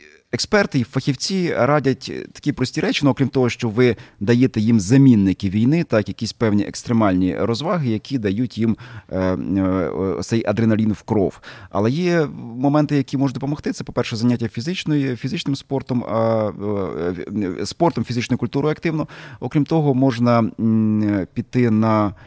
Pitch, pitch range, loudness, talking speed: 120 Hz, 110-140 Hz, -20 LUFS, 150 wpm